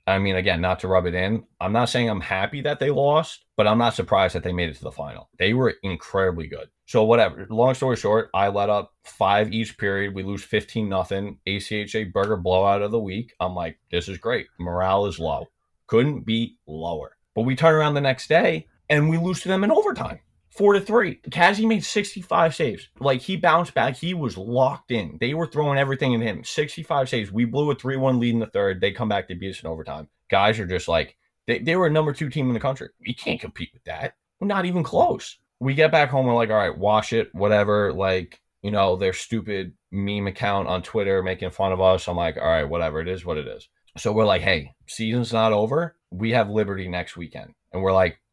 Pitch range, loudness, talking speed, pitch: 95-140 Hz, -23 LUFS, 235 wpm, 110 Hz